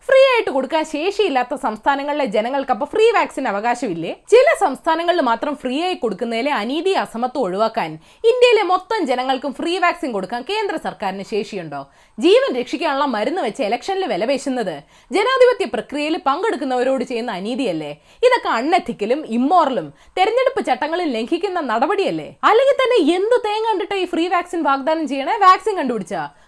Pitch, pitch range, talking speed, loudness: 295 Hz, 245-390 Hz, 130 wpm, -18 LUFS